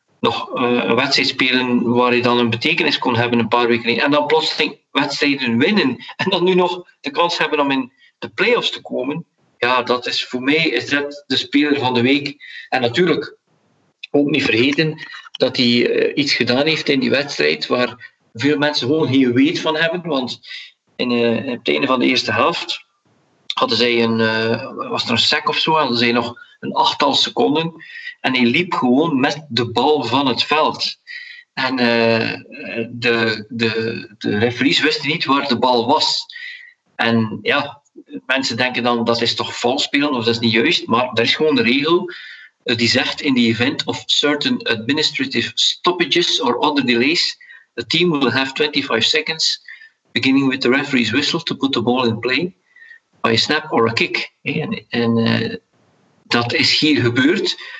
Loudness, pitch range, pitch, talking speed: -17 LUFS, 120-160 Hz, 130 Hz, 180 wpm